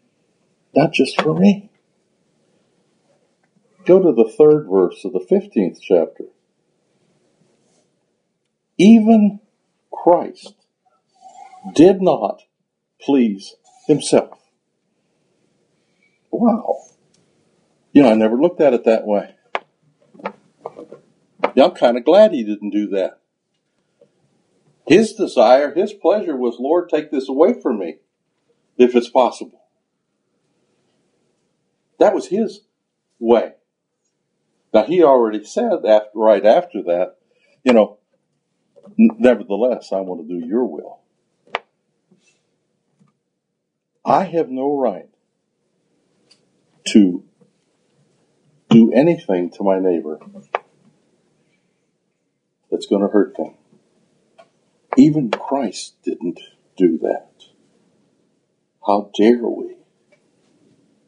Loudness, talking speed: -16 LUFS, 95 wpm